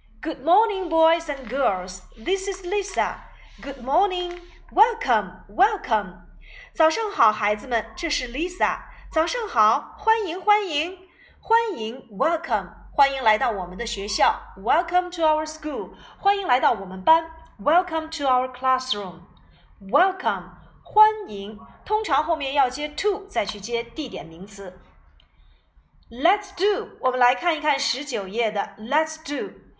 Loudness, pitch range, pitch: -23 LUFS, 230-370 Hz, 305 Hz